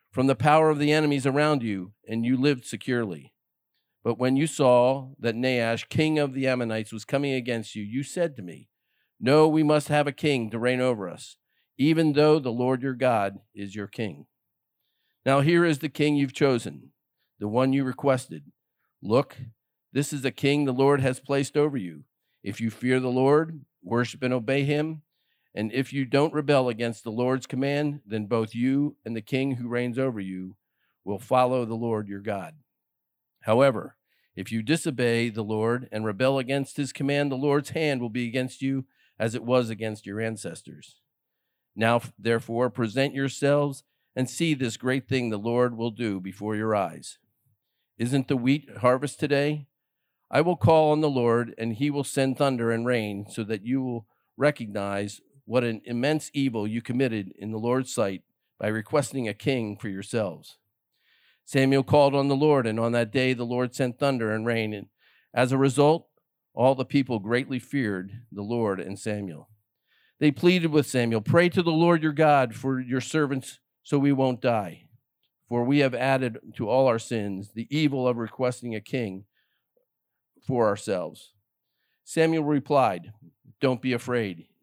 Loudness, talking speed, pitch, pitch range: -25 LUFS, 175 wpm, 130 Hz, 115-140 Hz